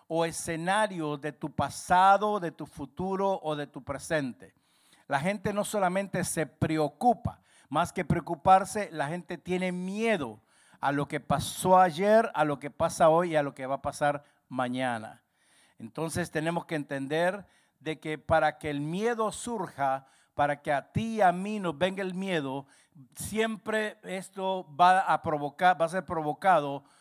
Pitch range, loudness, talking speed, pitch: 145-190 Hz, -29 LUFS, 165 wpm, 165 Hz